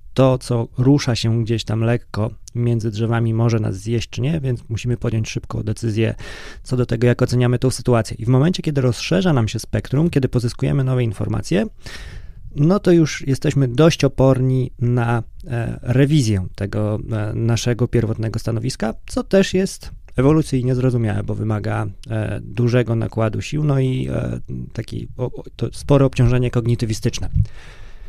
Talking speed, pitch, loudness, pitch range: 140 wpm, 120 Hz, -19 LUFS, 110-130 Hz